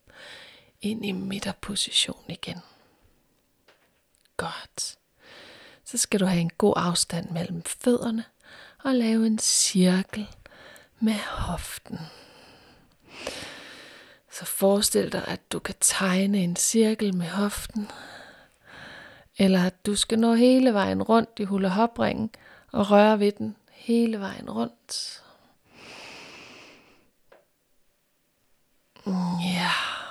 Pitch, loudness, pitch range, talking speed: 210 Hz, -25 LUFS, 190-230 Hz, 105 wpm